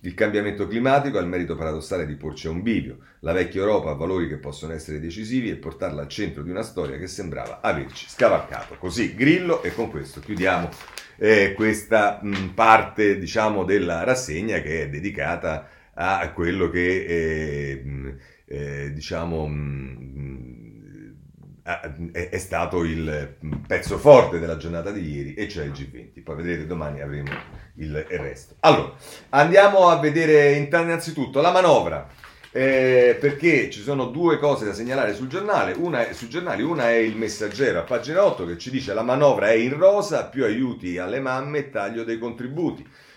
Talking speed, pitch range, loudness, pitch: 165 wpm, 80-130 Hz, -22 LUFS, 95 Hz